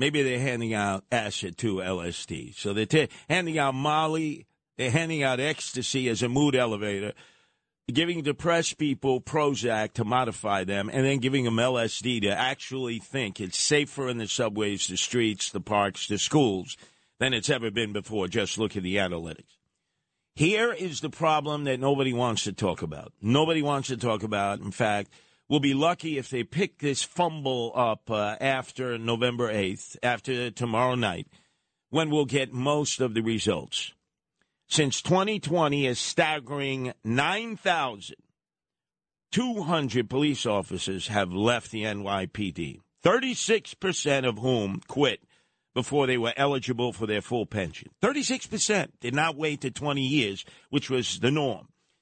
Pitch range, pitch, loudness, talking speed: 110-150 Hz, 125 Hz, -27 LUFS, 150 wpm